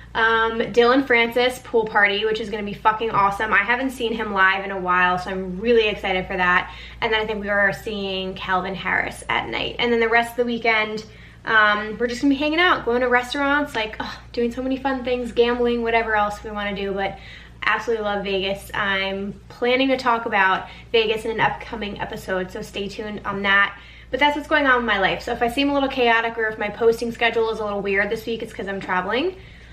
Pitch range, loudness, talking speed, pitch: 200-240 Hz, -21 LUFS, 240 wpm, 220 Hz